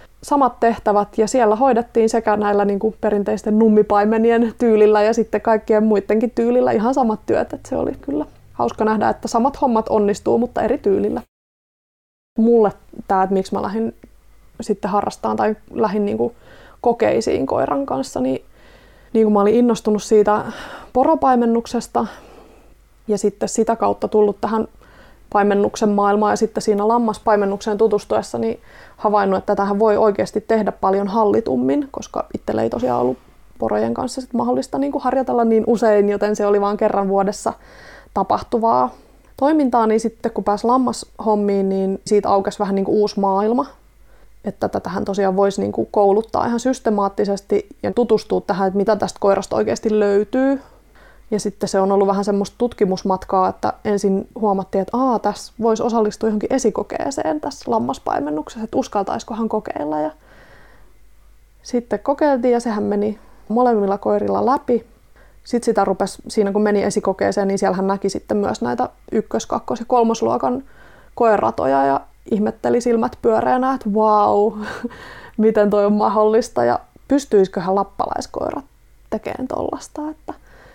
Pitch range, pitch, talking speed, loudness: 200-230 Hz, 215 Hz, 145 wpm, -18 LUFS